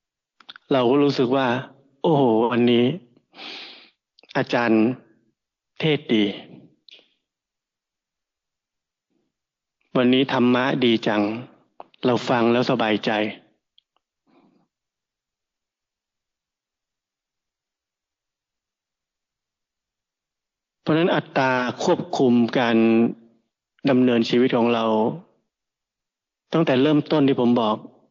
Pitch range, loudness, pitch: 115-135 Hz, -20 LUFS, 125 Hz